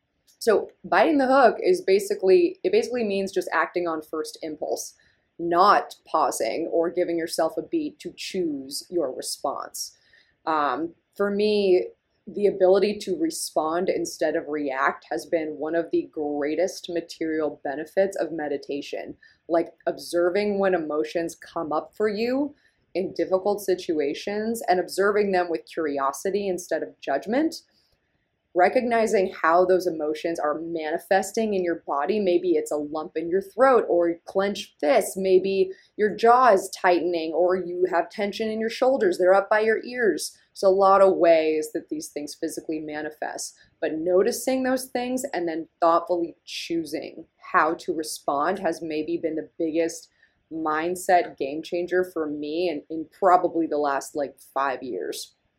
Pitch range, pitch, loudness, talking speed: 160-210 Hz, 180 Hz, -24 LUFS, 150 wpm